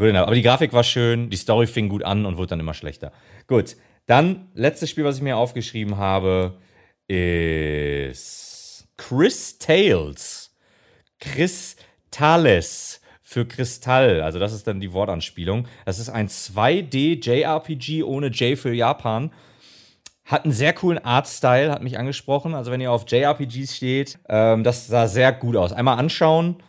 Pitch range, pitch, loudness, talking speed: 105-140 Hz, 120 Hz, -21 LUFS, 150 wpm